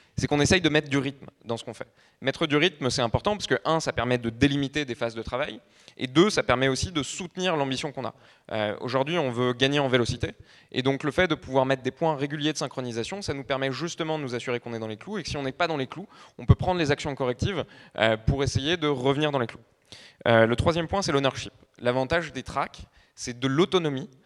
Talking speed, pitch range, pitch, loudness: 255 wpm, 125-155 Hz, 135 Hz, -26 LUFS